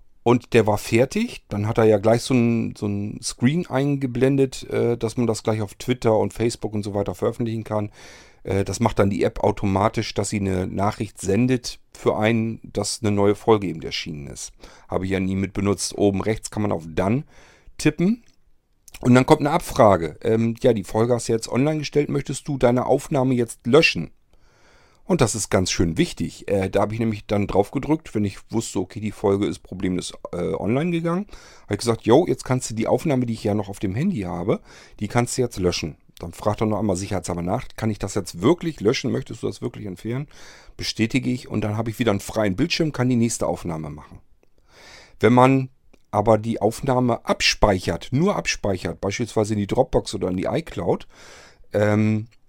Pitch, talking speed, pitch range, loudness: 110 Hz, 205 wpm, 100-125 Hz, -22 LUFS